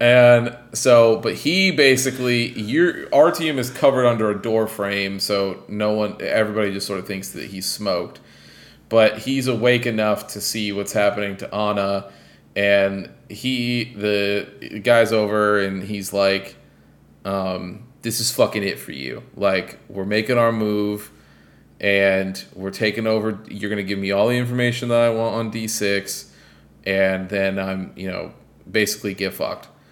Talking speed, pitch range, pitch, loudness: 160 wpm, 95-115 Hz, 105 Hz, -20 LUFS